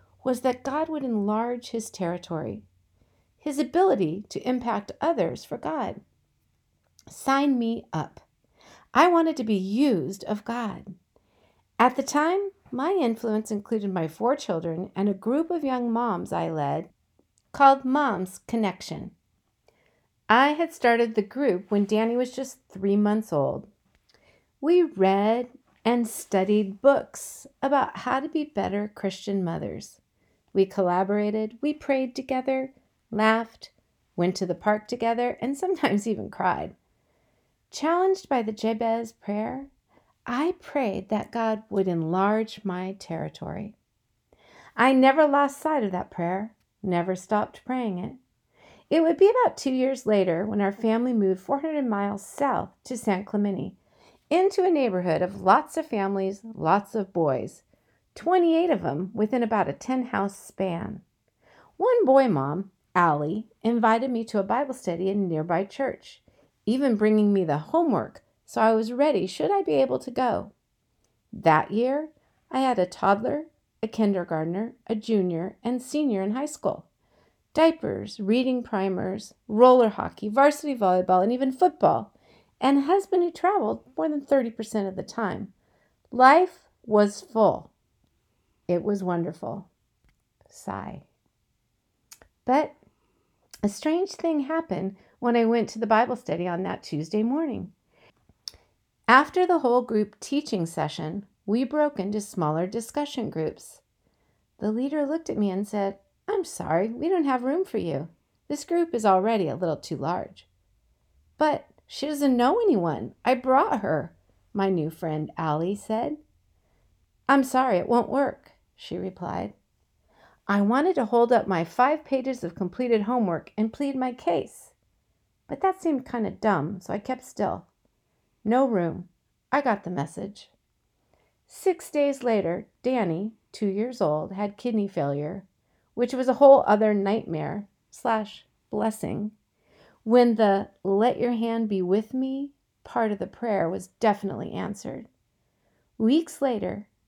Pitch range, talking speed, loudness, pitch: 195-270 Hz, 145 wpm, -25 LUFS, 225 Hz